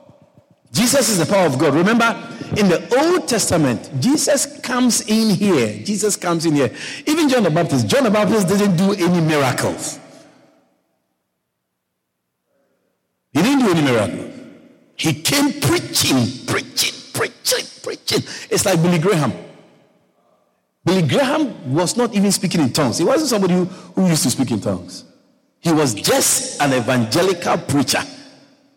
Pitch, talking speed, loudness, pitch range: 190 Hz, 145 wpm, -17 LUFS, 150-250 Hz